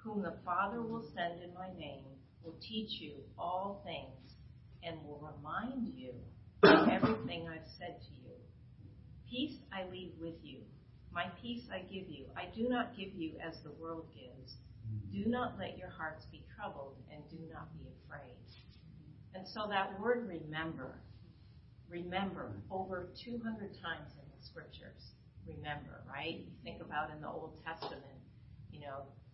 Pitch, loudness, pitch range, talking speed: 160 Hz, -39 LUFS, 130-190 Hz, 160 wpm